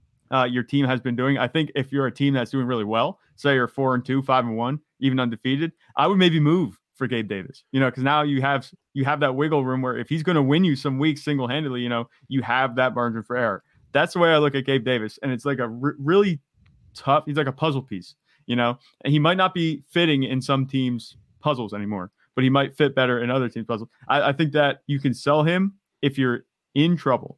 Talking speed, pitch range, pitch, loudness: 255 wpm, 125-150 Hz, 135 Hz, -23 LUFS